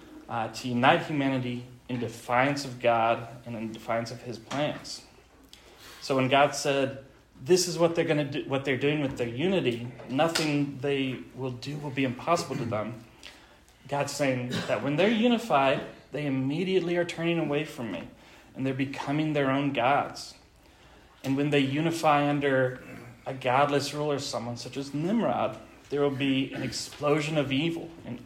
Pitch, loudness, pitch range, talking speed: 135 Hz, -28 LUFS, 125-150 Hz, 170 wpm